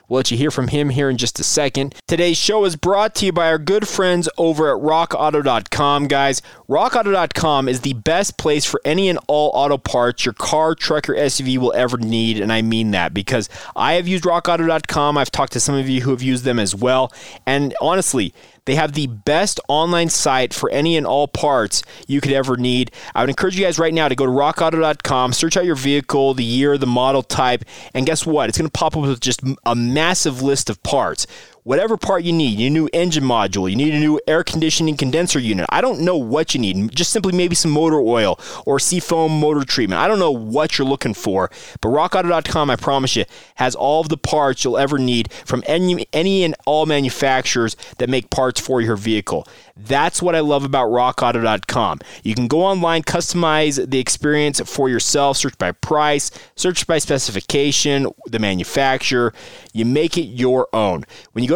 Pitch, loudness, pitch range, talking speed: 140 Hz, -17 LUFS, 125-160 Hz, 205 wpm